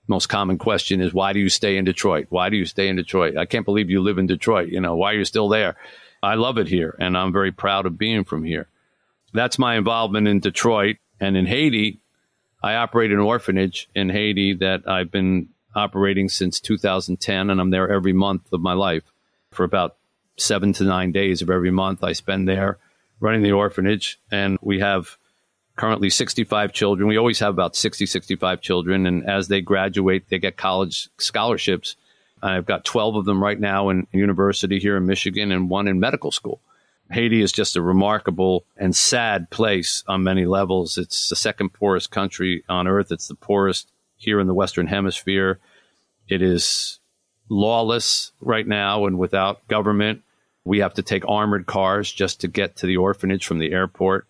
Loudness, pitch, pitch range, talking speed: -20 LUFS, 95 Hz, 95-100 Hz, 190 wpm